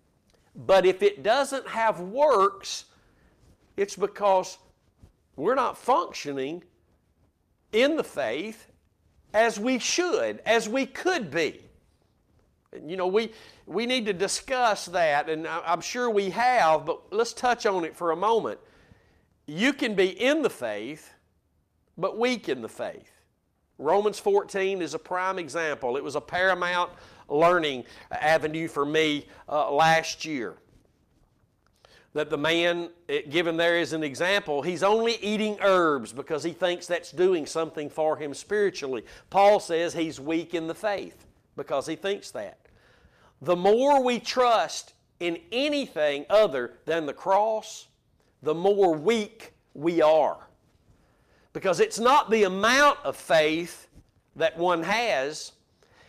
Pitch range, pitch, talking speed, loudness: 160-230 Hz, 190 Hz, 140 wpm, -25 LUFS